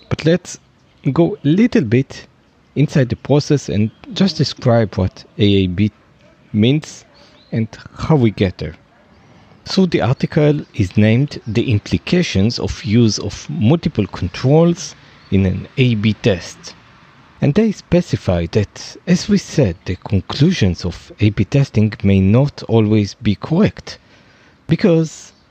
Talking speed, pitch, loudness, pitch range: 125 wpm, 120 Hz, -16 LUFS, 105-155 Hz